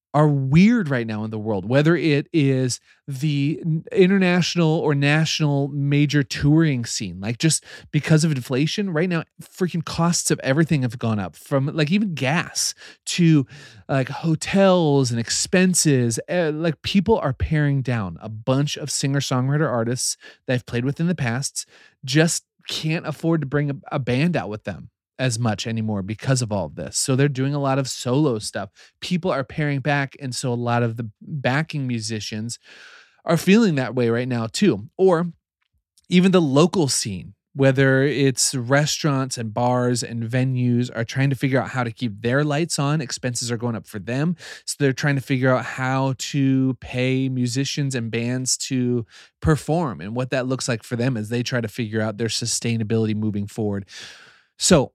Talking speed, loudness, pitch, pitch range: 180 wpm, -21 LUFS, 135 Hz, 120-155 Hz